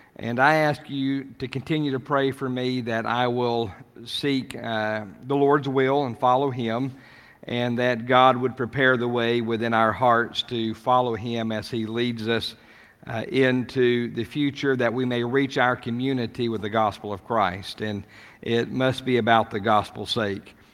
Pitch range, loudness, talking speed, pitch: 115-130 Hz, -24 LUFS, 175 wpm, 120 Hz